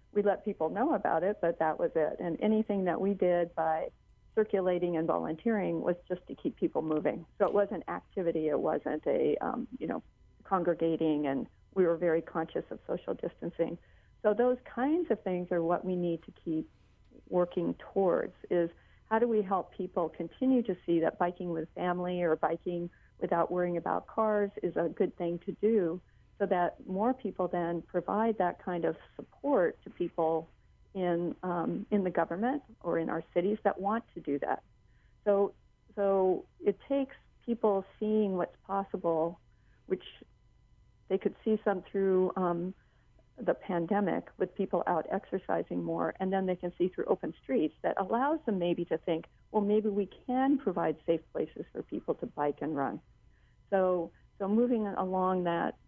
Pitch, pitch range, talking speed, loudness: 180 Hz, 170-205 Hz, 175 wpm, -32 LUFS